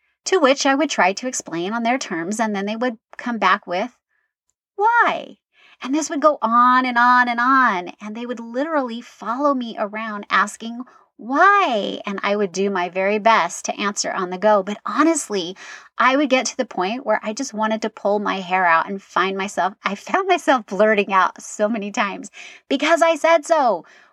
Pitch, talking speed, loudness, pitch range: 230 Hz, 200 wpm, -19 LUFS, 200-275 Hz